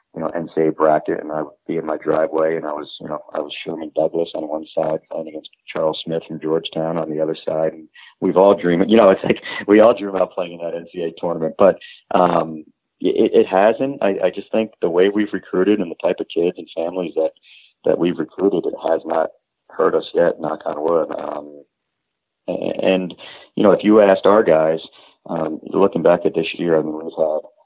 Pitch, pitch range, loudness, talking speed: 80 Hz, 80-85 Hz, -19 LUFS, 225 wpm